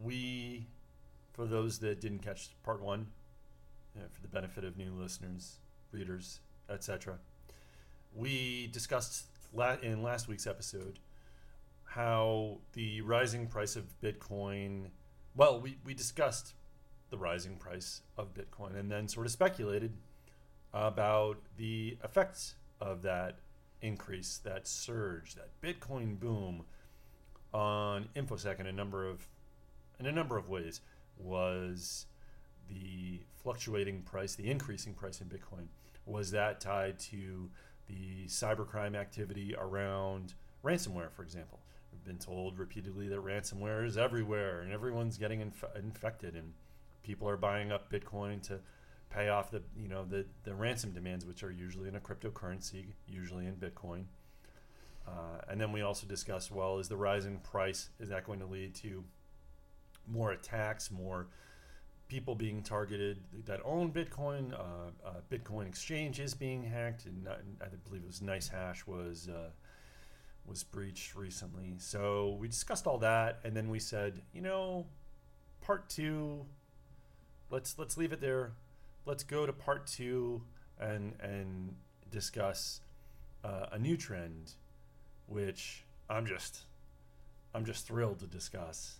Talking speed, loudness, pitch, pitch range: 140 wpm, -40 LUFS, 100 Hz, 90-110 Hz